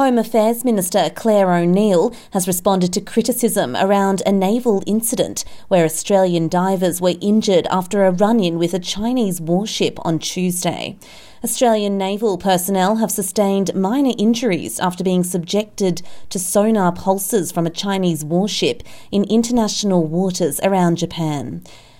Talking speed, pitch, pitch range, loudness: 135 wpm, 195 Hz, 180-215 Hz, -18 LUFS